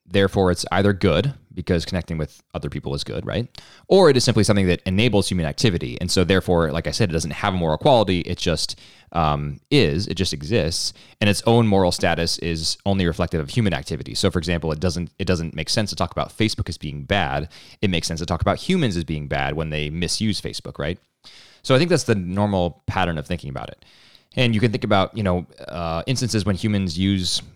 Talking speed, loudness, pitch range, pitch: 230 wpm, -21 LUFS, 80-100 Hz, 90 Hz